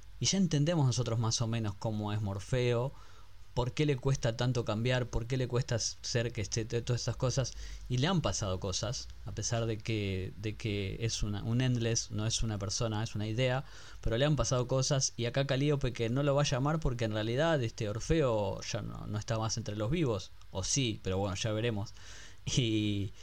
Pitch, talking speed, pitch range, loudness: 115 Hz, 210 wpm, 105-130 Hz, -33 LUFS